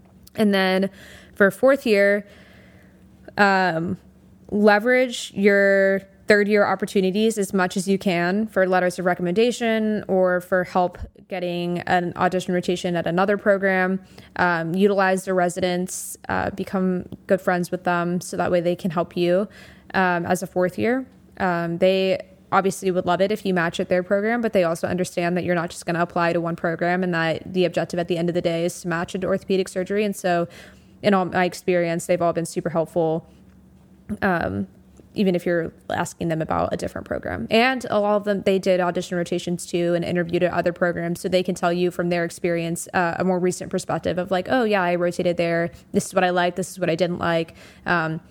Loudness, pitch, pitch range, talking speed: -22 LUFS, 180 Hz, 175-195 Hz, 200 wpm